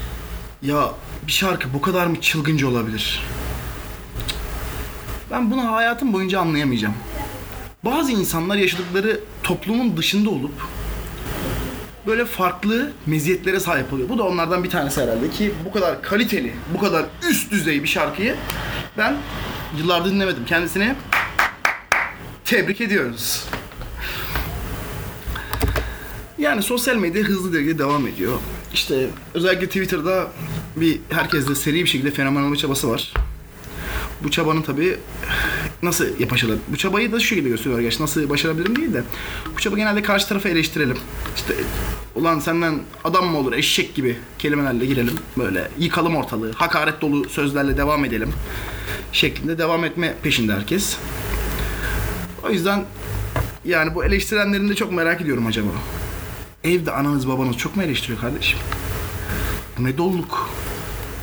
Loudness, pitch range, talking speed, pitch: -21 LUFS, 125-185 Hz, 125 wpm, 155 Hz